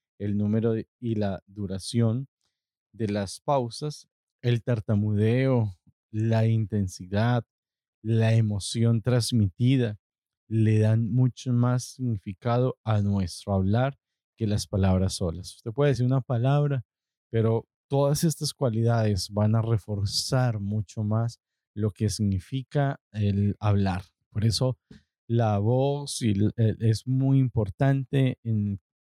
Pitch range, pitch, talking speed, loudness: 105-125 Hz, 110 Hz, 120 wpm, -26 LUFS